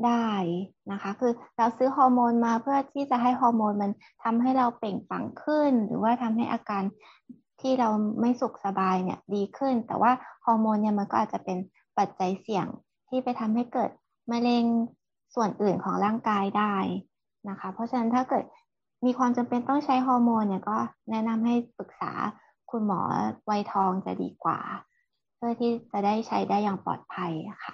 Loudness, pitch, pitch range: -27 LUFS, 230 Hz, 205-245 Hz